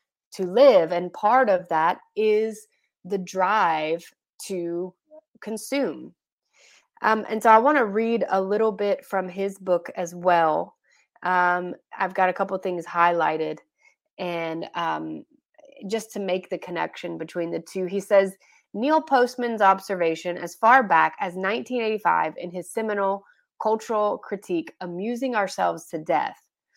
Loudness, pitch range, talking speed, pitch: -23 LUFS, 180-225 Hz, 140 wpm, 195 Hz